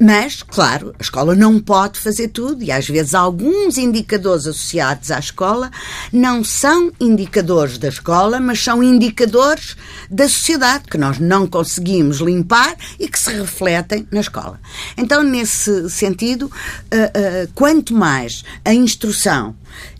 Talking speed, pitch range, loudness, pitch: 130 wpm, 165-240 Hz, -15 LUFS, 205 Hz